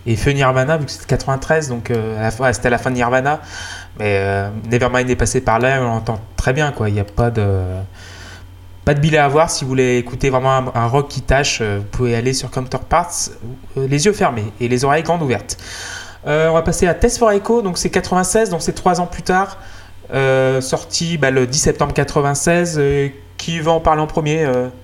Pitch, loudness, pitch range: 130 Hz, -17 LUFS, 110-155 Hz